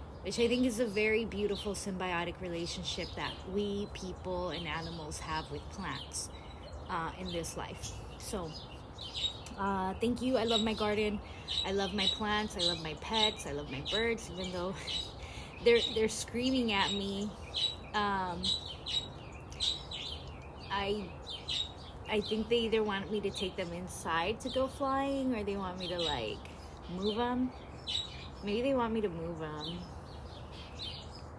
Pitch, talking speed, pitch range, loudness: 195 Hz, 150 wpm, 165-220 Hz, -34 LUFS